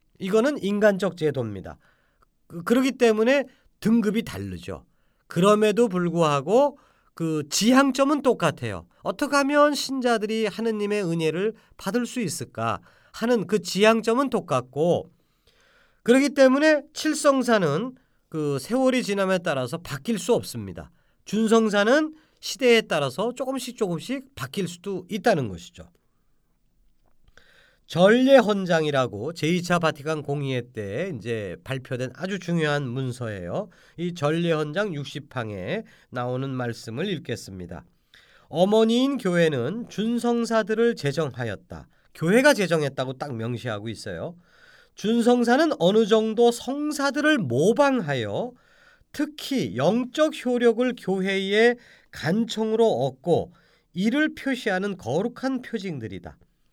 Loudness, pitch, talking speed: -23 LUFS, 200 Hz, 265 characters per minute